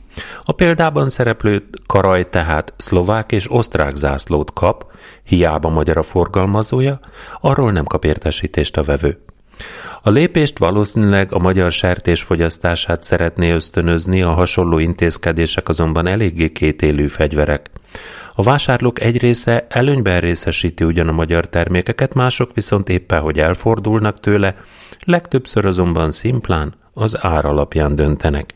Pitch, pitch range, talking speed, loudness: 90 Hz, 80-110 Hz, 125 wpm, -16 LUFS